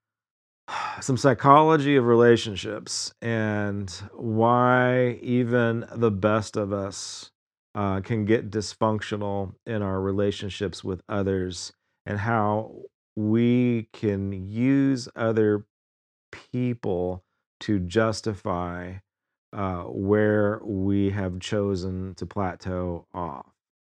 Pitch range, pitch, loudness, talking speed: 95-115 Hz, 105 Hz, -25 LUFS, 95 wpm